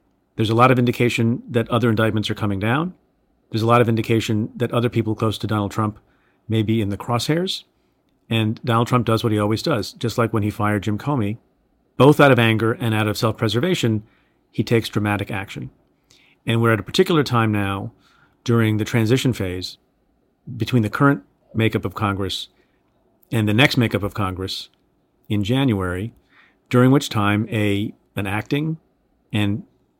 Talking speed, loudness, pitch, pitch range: 175 wpm, -20 LUFS, 110 Hz, 105-120 Hz